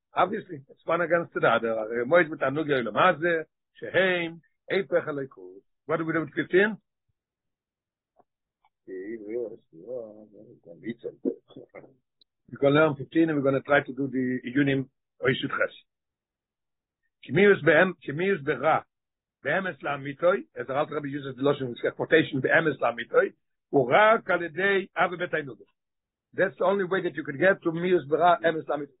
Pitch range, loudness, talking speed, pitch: 145-185 Hz, -25 LUFS, 155 wpm, 165 Hz